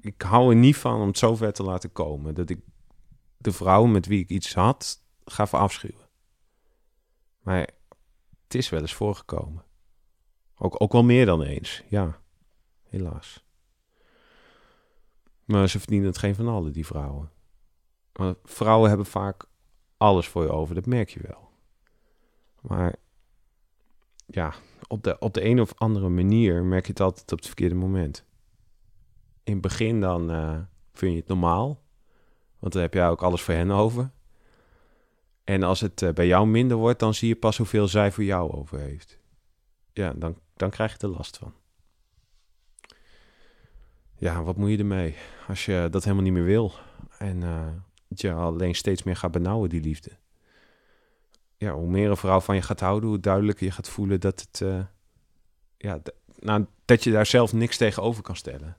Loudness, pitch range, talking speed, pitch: -24 LUFS, 85-105 Hz, 170 wpm, 95 Hz